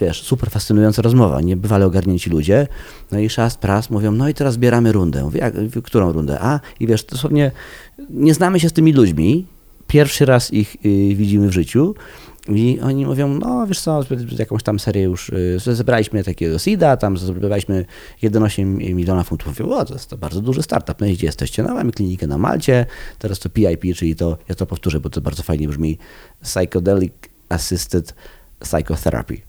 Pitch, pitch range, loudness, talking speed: 105 Hz, 90-125 Hz, -17 LUFS, 175 wpm